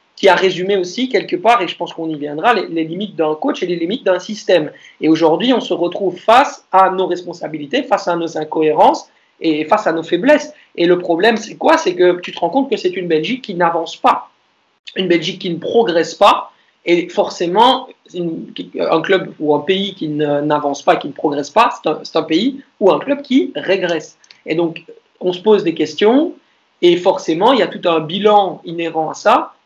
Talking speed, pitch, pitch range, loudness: 215 wpm, 180 Hz, 165-215 Hz, -15 LUFS